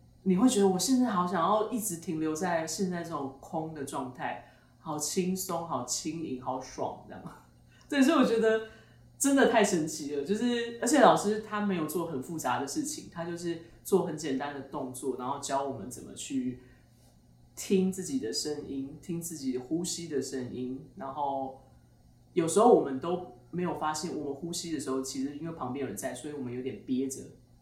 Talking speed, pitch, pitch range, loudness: 280 characters per minute, 160 Hz, 135-185 Hz, -31 LUFS